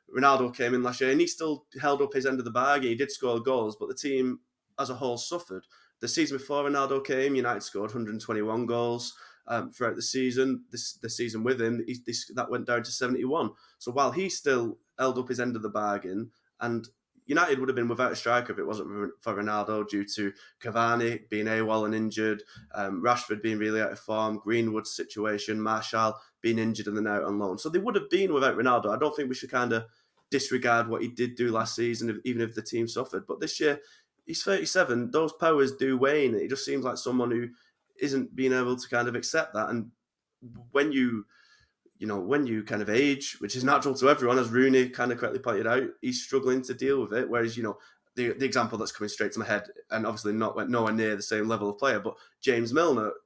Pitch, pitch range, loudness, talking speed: 120 Hz, 110-135 Hz, -28 LUFS, 225 wpm